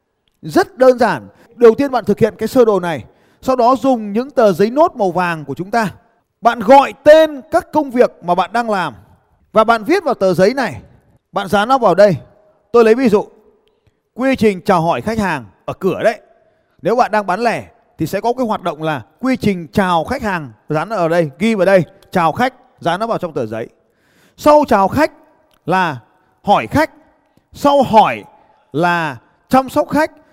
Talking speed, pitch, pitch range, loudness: 200 wpm, 220 Hz, 180-260 Hz, -15 LUFS